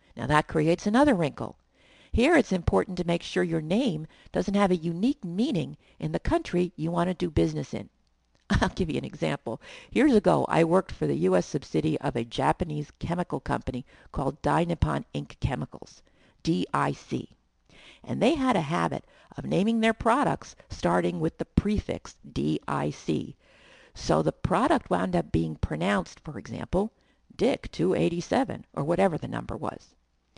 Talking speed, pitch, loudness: 155 wpm, 165 Hz, -27 LUFS